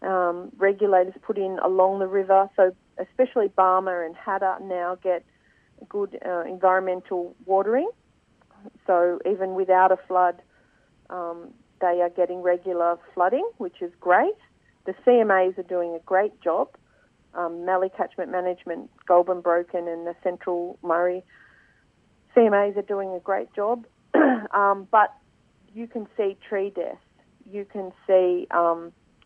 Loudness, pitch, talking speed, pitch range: -24 LUFS, 185 Hz, 135 wpm, 180-200 Hz